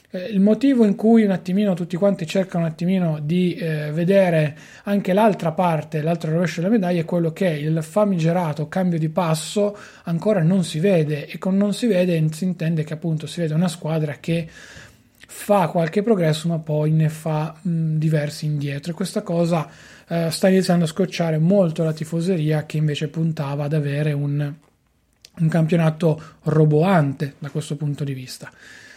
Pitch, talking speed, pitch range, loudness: 165 Hz, 170 wpm, 155-185 Hz, -21 LUFS